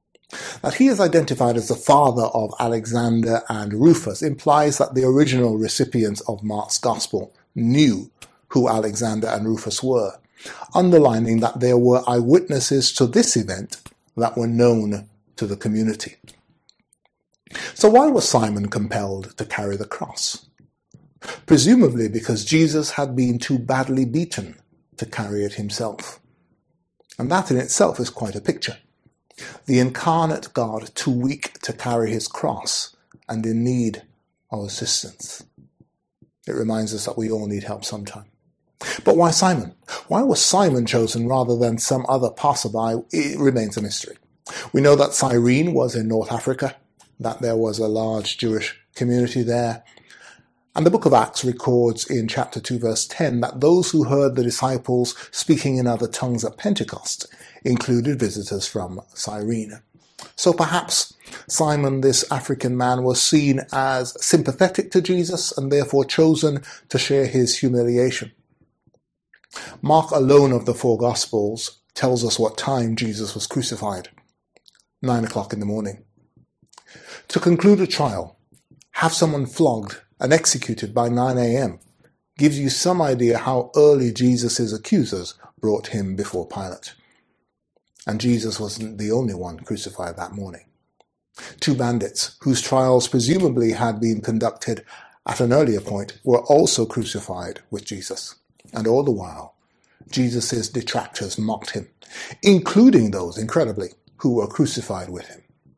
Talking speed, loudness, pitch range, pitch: 145 wpm, -20 LUFS, 110-135 Hz, 120 Hz